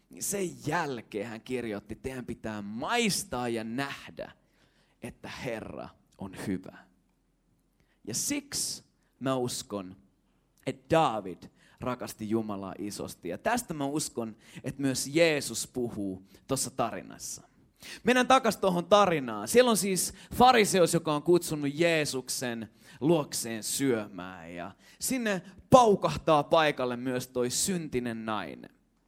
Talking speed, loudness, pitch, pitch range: 115 wpm, -29 LUFS, 135 Hz, 115-175 Hz